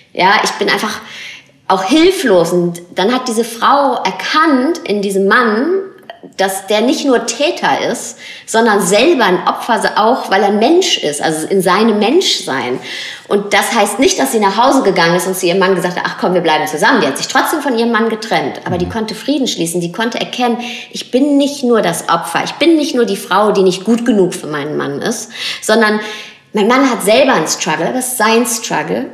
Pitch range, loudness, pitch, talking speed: 190-250 Hz, -13 LUFS, 215 Hz, 210 wpm